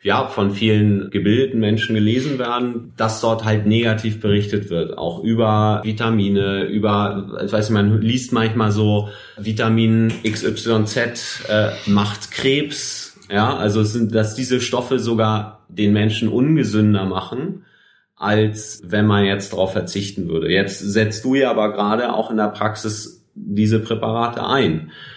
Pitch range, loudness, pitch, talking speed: 105-115 Hz, -19 LUFS, 110 Hz, 140 wpm